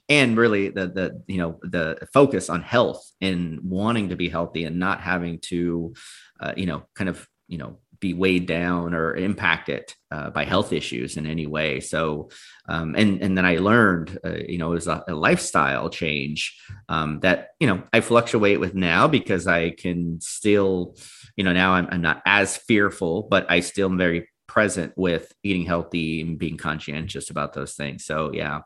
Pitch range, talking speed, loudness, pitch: 80-95 Hz, 190 wpm, -23 LUFS, 85 Hz